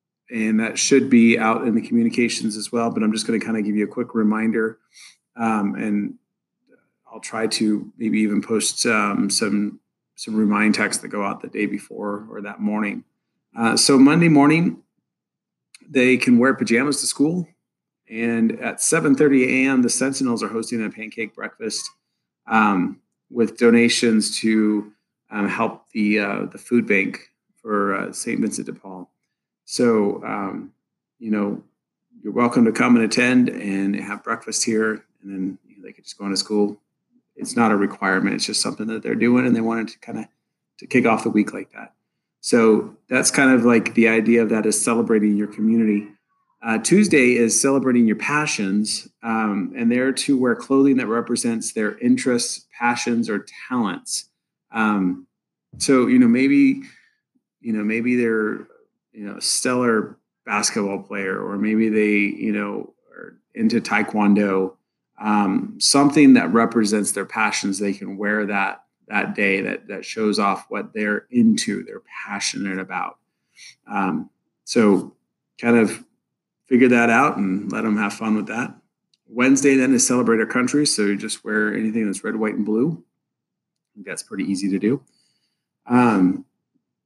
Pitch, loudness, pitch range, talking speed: 115 Hz, -20 LUFS, 105-125 Hz, 165 wpm